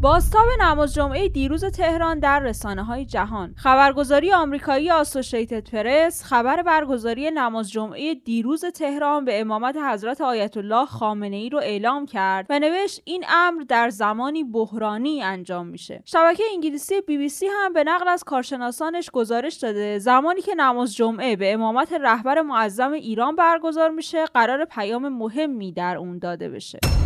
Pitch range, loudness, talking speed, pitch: 230-320 Hz, -21 LUFS, 150 wpm, 275 Hz